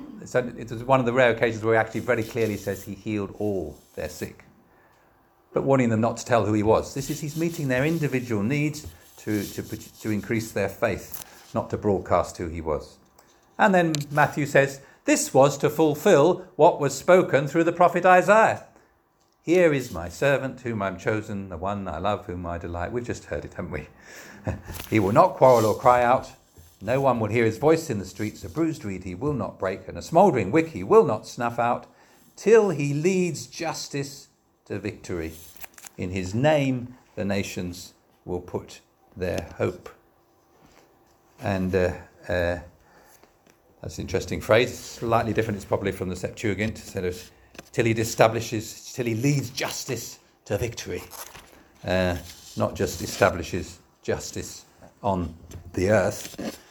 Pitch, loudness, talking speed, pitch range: 110 Hz, -24 LUFS, 170 wpm, 95-140 Hz